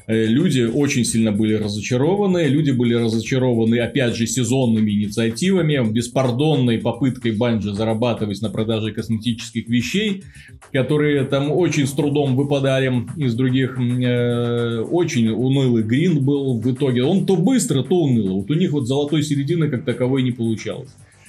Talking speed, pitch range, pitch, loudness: 140 wpm, 115-145 Hz, 125 Hz, -19 LUFS